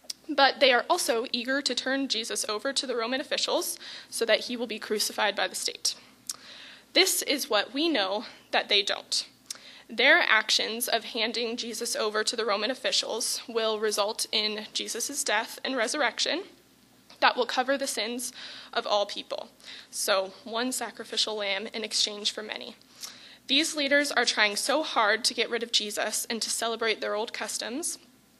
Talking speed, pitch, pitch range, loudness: 170 wpm, 235 Hz, 220-275 Hz, -27 LUFS